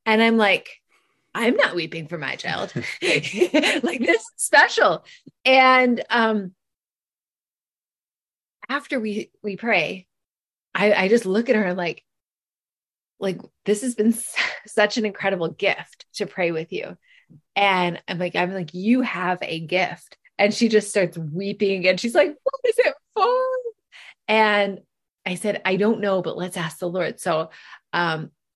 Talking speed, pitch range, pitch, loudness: 155 wpm, 185-235 Hz, 205 Hz, -21 LUFS